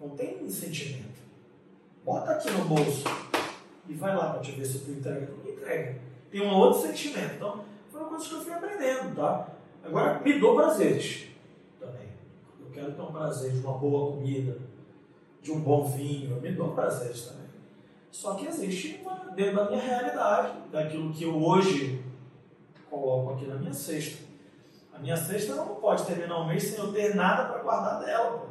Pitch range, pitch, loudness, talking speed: 145-205 Hz, 160 Hz, -29 LUFS, 185 wpm